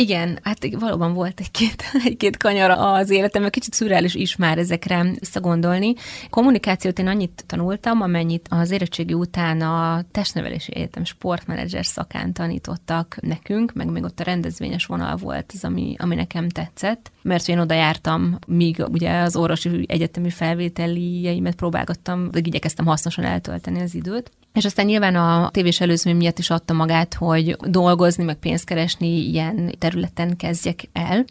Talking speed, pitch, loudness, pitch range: 150 wpm, 175 Hz, -21 LUFS, 165-190 Hz